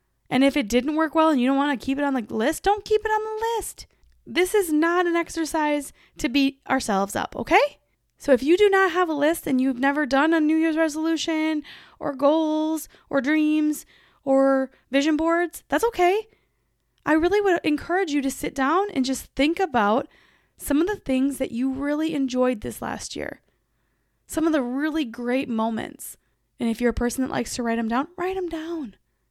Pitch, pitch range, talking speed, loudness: 300 Hz, 270-330 Hz, 205 wpm, -23 LUFS